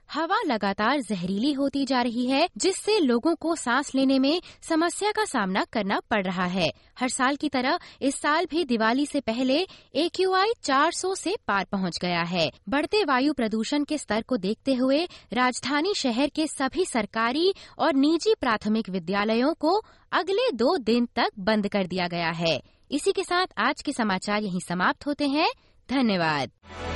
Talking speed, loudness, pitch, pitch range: 170 wpm, -25 LUFS, 265 Hz, 210-320 Hz